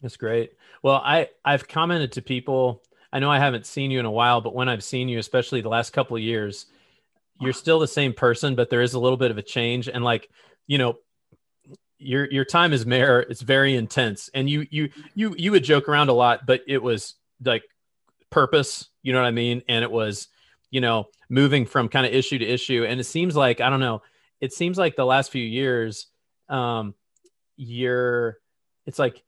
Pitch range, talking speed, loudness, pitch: 120-140 Hz, 215 wpm, -22 LUFS, 130 Hz